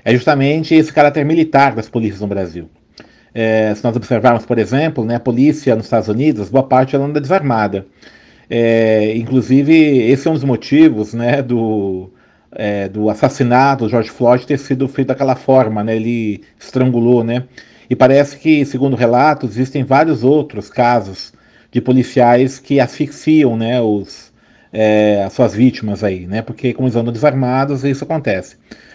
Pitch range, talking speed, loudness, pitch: 110-140 Hz, 160 wpm, -14 LUFS, 125 Hz